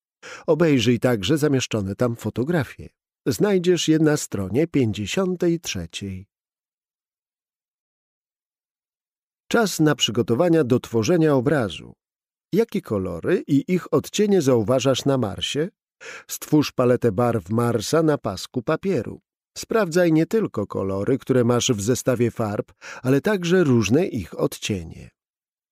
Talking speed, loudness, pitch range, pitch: 105 wpm, -21 LUFS, 115-160 Hz, 130 Hz